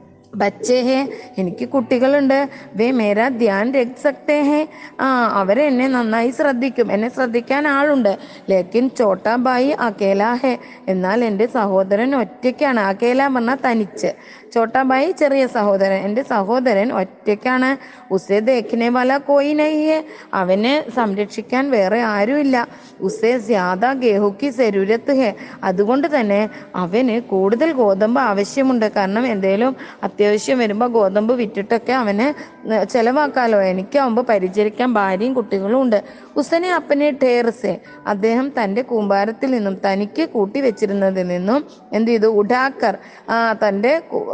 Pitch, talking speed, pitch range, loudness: 240 Hz, 110 wpm, 205-265 Hz, -17 LUFS